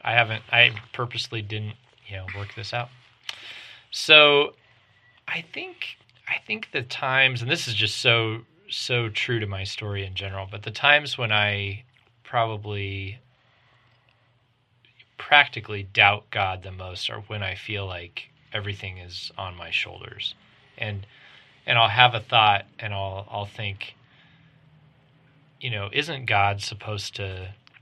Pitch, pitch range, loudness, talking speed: 115 Hz, 100-125 Hz, -23 LUFS, 140 wpm